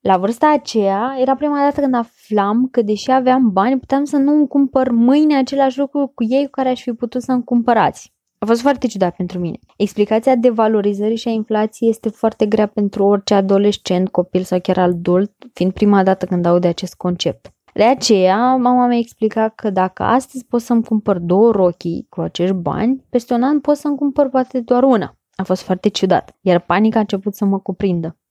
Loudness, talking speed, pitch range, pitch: -16 LUFS, 205 wpm, 195-255 Hz, 220 Hz